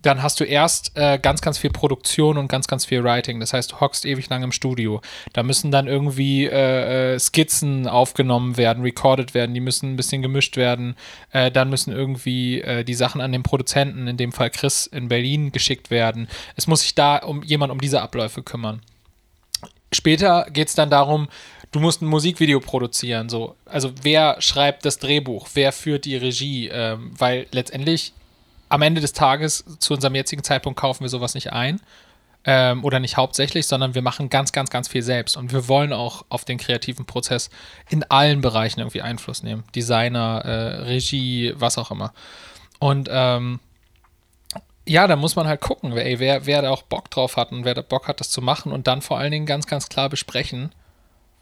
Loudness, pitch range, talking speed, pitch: -20 LUFS, 120-145 Hz, 195 wpm, 130 Hz